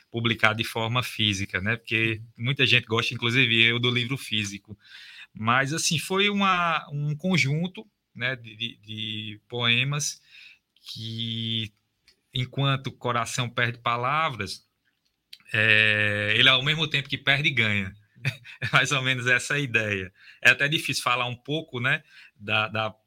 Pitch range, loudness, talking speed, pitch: 110-140 Hz, -24 LUFS, 140 wpm, 120 Hz